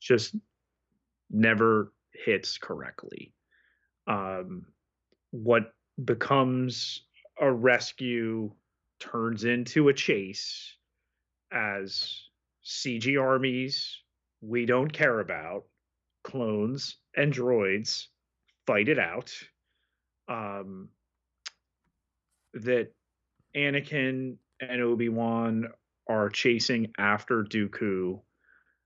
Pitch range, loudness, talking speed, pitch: 100-125 Hz, -28 LUFS, 75 wpm, 115 Hz